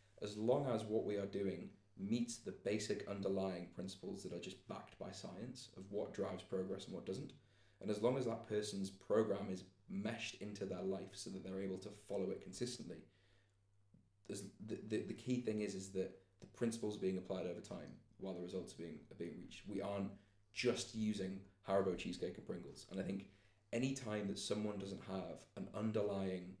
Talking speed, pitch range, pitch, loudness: 195 wpm, 95-105 Hz, 100 Hz, -44 LUFS